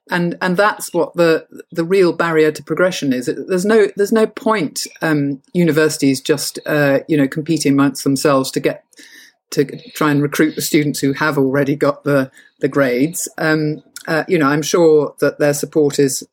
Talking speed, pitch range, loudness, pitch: 185 wpm, 145-170 Hz, -16 LUFS, 155 Hz